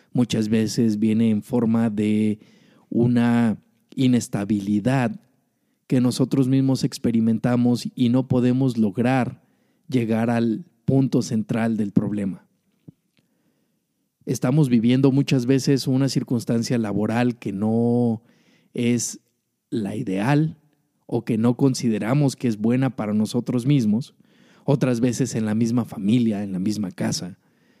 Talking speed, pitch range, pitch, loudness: 115 wpm, 115-135 Hz, 120 Hz, -22 LUFS